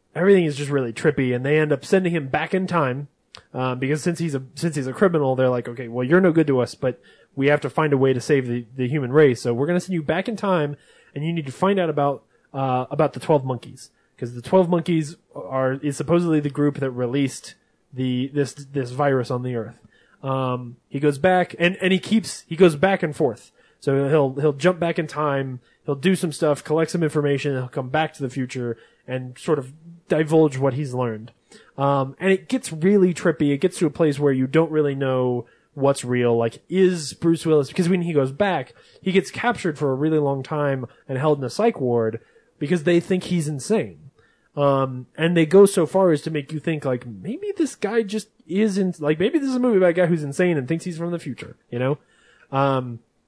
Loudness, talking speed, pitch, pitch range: -22 LUFS, 235 wpm, 150 Hz, 130-170 Hz